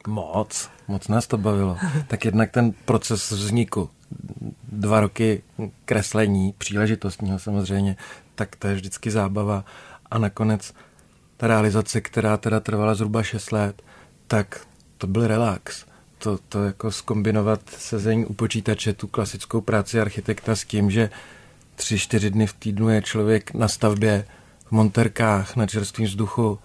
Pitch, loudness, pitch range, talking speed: 110 Hz, -23 LUFS, 105-110 Hz, 140 wpm